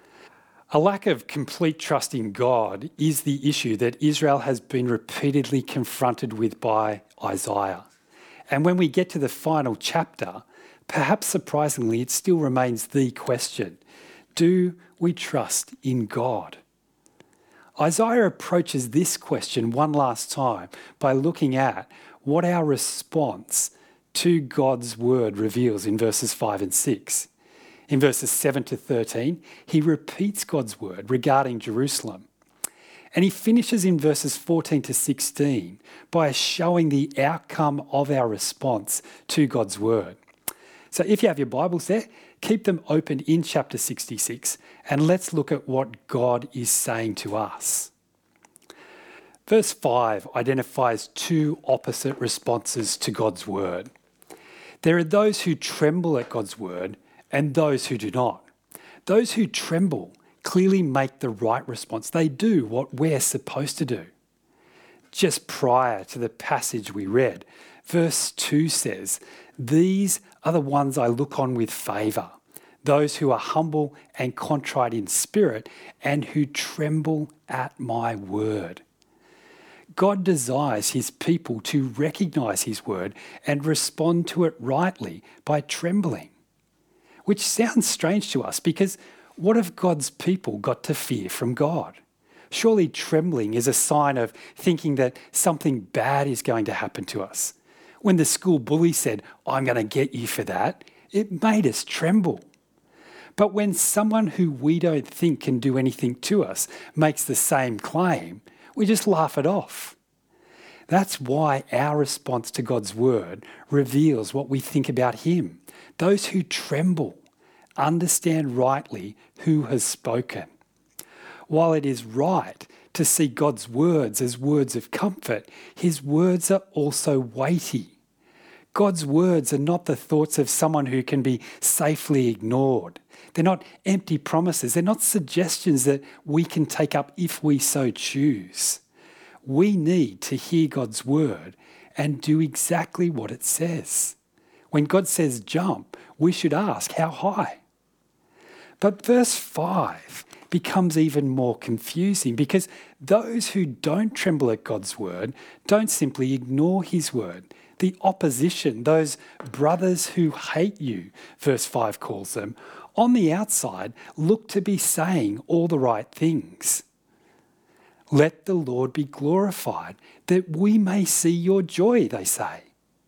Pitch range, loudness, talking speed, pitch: 130-175 Hz, -23 LUFS, 140 wpm, 150 Hz